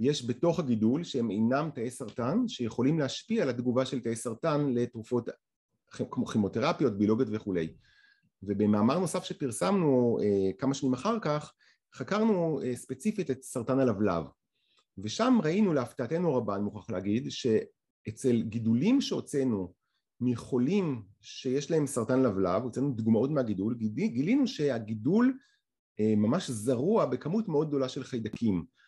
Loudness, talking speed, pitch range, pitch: -30 LUFS, 125 wpm, 115-160 Hz, 130 Hz